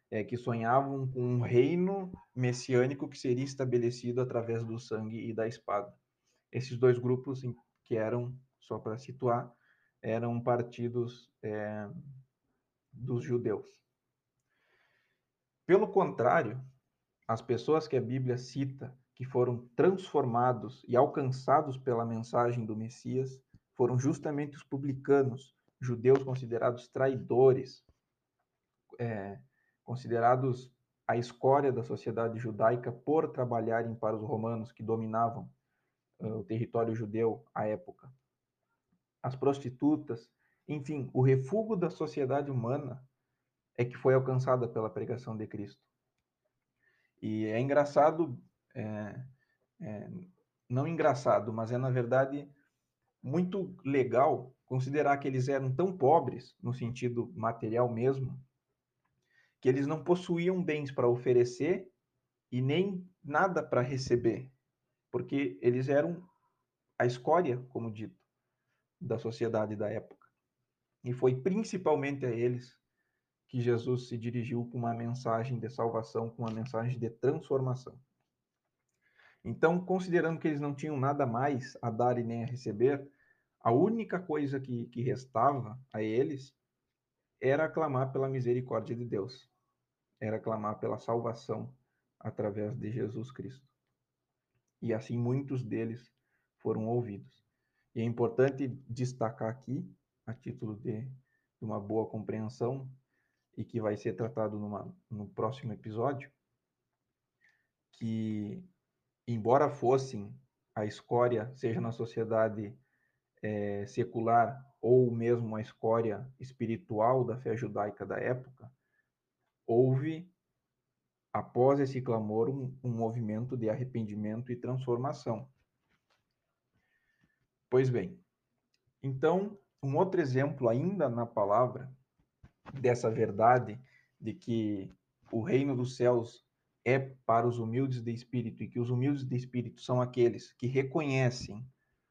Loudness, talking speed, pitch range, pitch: -32 LUFS, 120 wpm, 115-135 Hz, 125 Hz